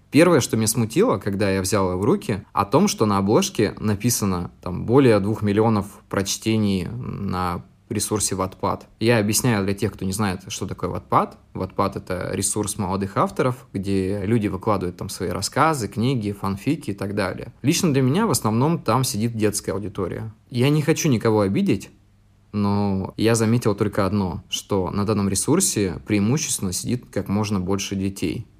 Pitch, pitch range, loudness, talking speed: 105 Hz, 100-115 Hz, -22 LUFS, 165 wpm